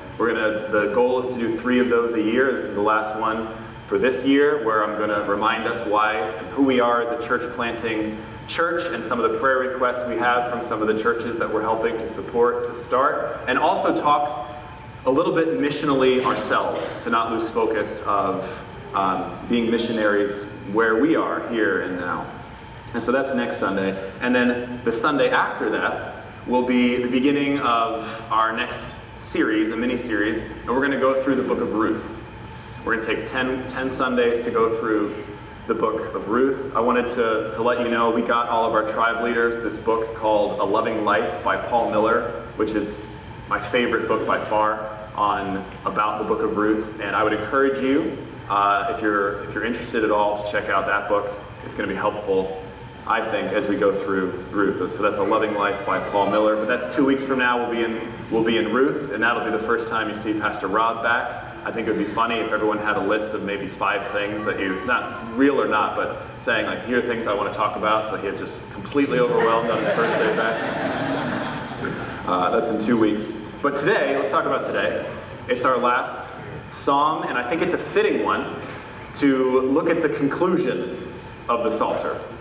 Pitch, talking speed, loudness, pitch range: 115 Hz, 215 wpm, -22 LUFS, 110-125 Hz